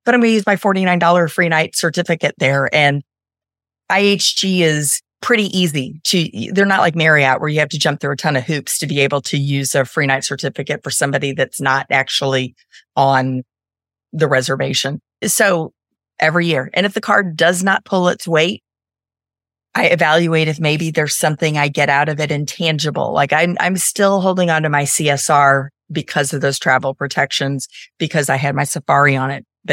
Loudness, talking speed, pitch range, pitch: -15 LUFS, 190 wpm, 135-170 Hz, 150 Hz